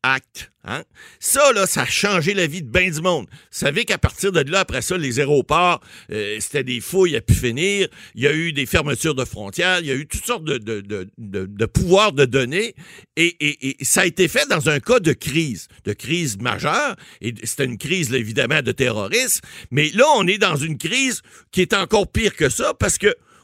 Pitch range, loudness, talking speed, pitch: 125-185 Hz, -19 LUFS, 230 wpm, 150 Hz